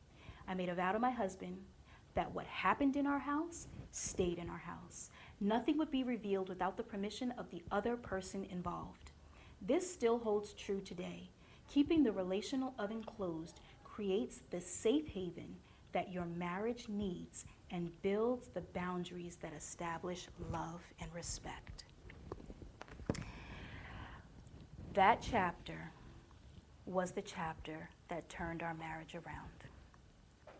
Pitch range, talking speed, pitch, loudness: 170-215 Hz, 130 wpm, 185 Hz, -40 LUFS